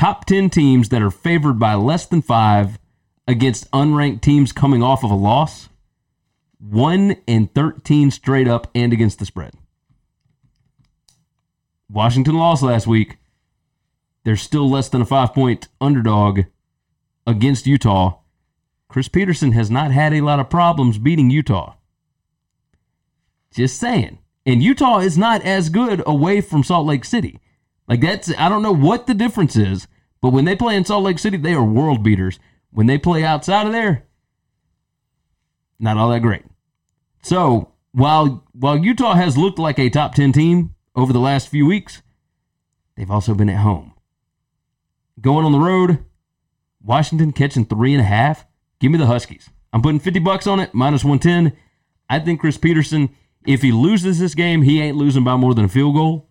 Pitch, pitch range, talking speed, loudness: 140 Hz, 115-165 Hz, 165 wpm, -16 LUFS